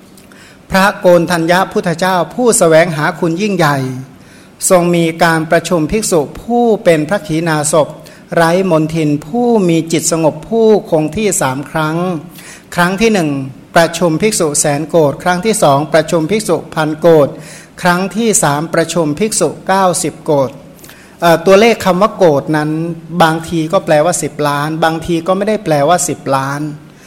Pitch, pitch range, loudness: 165 Hz, 155-185 Hz, -12 LUFS